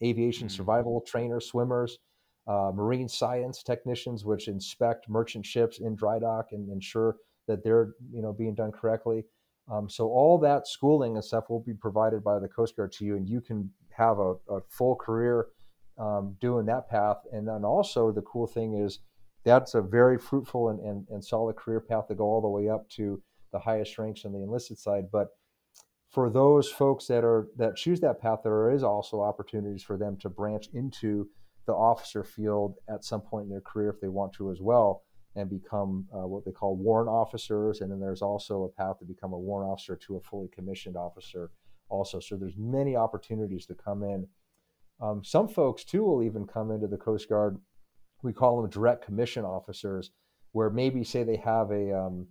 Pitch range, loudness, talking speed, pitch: 100-115 Hz, -29 LUFS, 200 wpm, 105 Hz